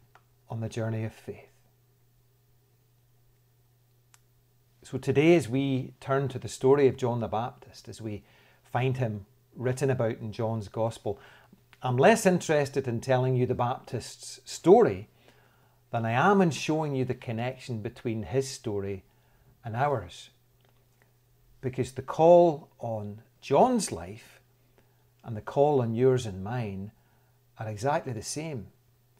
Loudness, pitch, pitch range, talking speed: -27 LUFS, 125 Hz, 115-130 Hz, 135 wpm